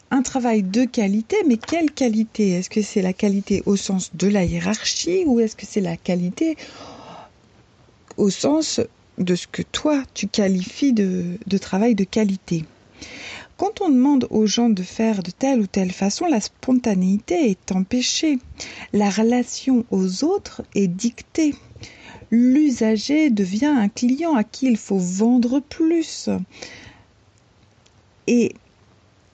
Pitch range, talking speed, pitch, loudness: 195-265 Hz, 140 wpm, 220 Hz, -20 LUFS